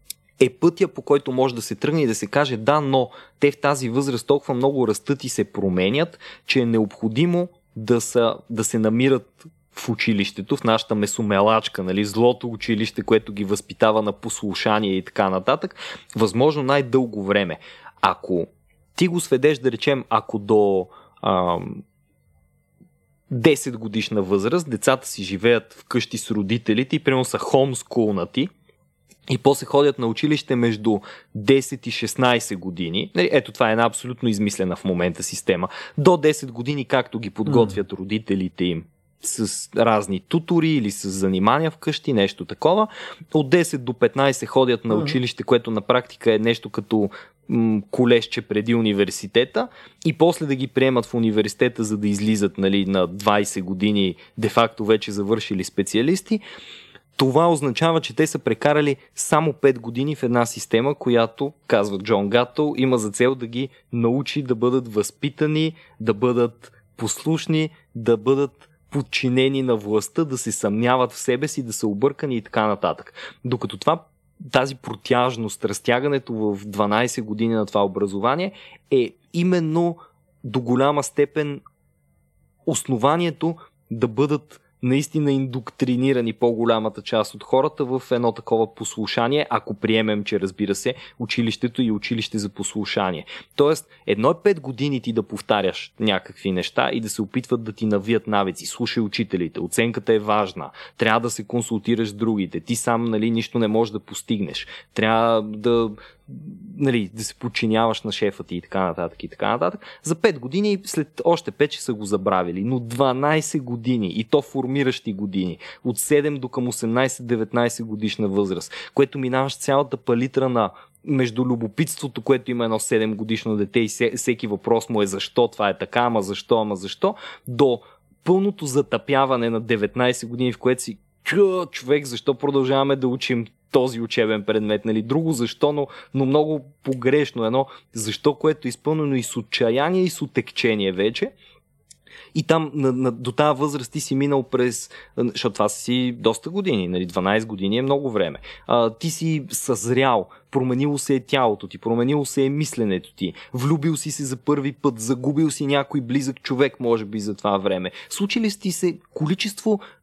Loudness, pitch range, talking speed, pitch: -22 LUFS, 110-140 Hz, 160 wpm, 120 Hz